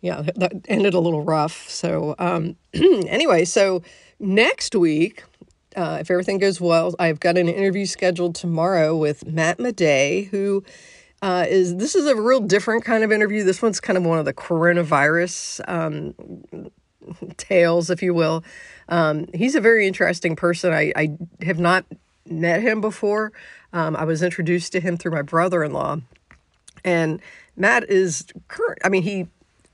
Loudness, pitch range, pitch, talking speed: -20 LUFS, 165-200 Hz, 180 Hz, 165 wpm